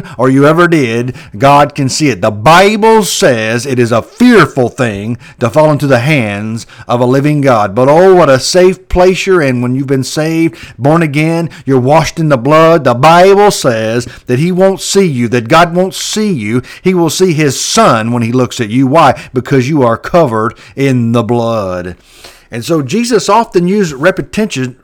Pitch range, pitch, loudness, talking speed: 120-170 Hz, 140 Hz, -9 LUFS, 195 wpm